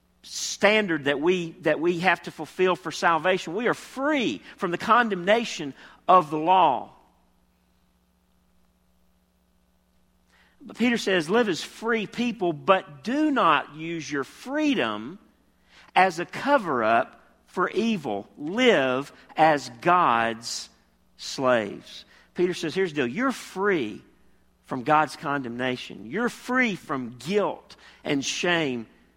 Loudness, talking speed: -24 LUFS, 115 wpm